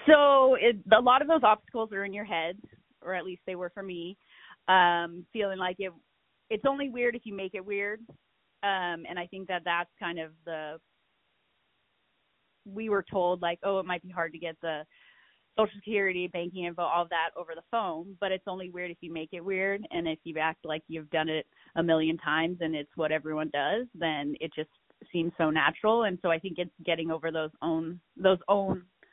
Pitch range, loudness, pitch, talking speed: 165-200 Hz, -29 LUFS, 180 Hz, 210 wpm